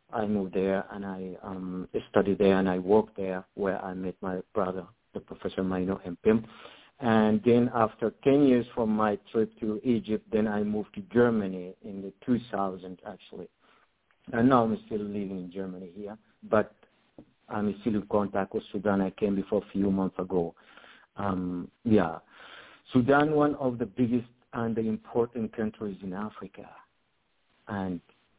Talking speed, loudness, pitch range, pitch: 160 wpm, -29 LUFS, 95-115 Hz, 105 Hz